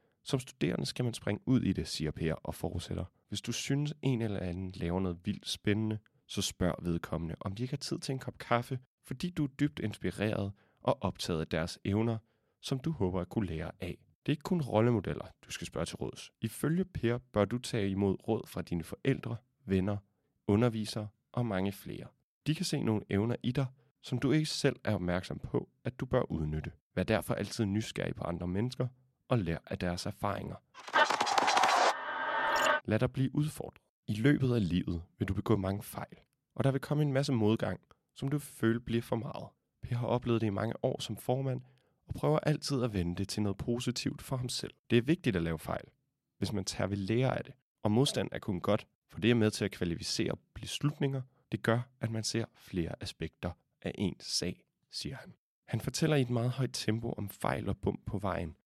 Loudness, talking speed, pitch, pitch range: -34 LUFS, 210 wpm, 115 Hz, 100-130 Hz